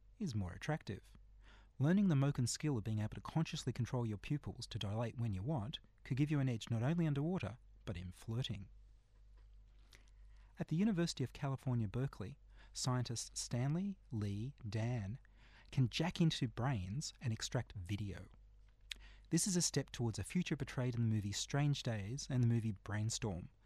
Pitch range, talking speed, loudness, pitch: 105-140 Hz, 165 wpm, -40 LUFS, 115 Hz